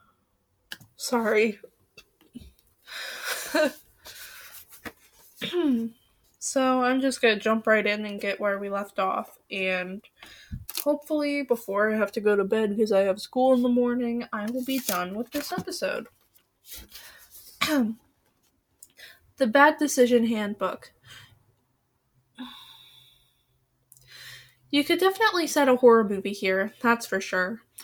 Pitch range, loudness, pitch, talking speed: 195-265 Hz, -25 LUFS, 225 Hz, 115 wpm